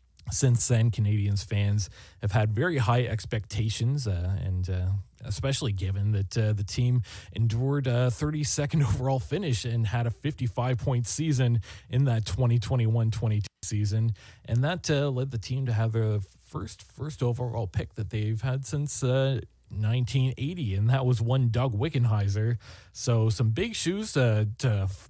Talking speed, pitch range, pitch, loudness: 155 wpm, 105-130 Hz, 115 Hz, -28 LUFS